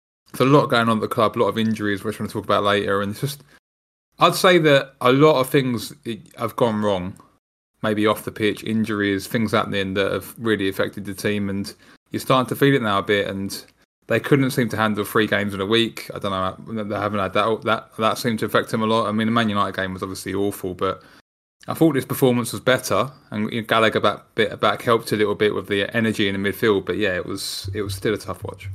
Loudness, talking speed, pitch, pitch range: -21 LUFS, 255 wpm, 105 Hz, 100-115 Hz